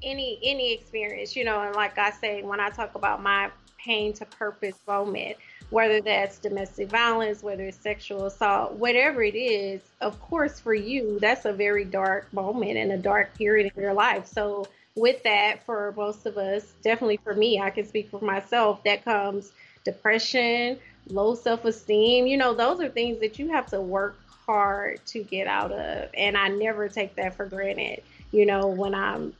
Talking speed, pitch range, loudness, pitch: 190 wpm, 200-225 Hz, -25 LUFS, 210 Hz